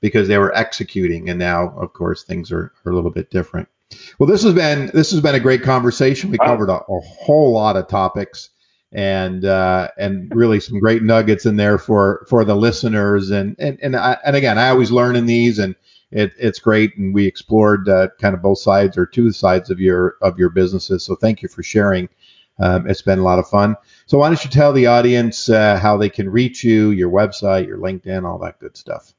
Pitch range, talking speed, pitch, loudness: 95-120 Hz, 225 wpm, 105 Hz, -15 LUFS